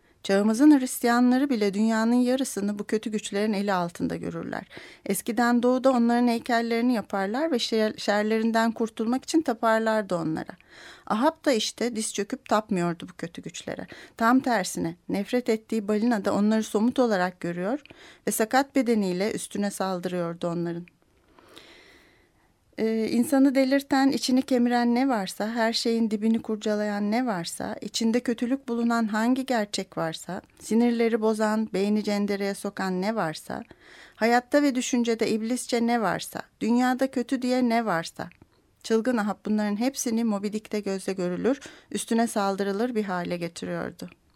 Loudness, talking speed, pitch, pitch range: -25 LUFS, 130 wpm, 225 Hz, 205-245 Hz